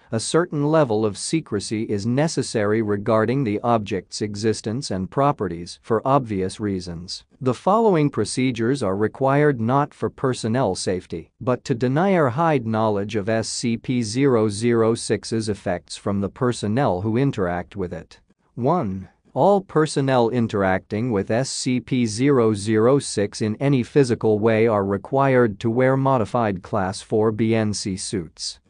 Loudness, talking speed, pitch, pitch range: -21 LUFS, 125 wpm, 115 Hz, 105-130 Hz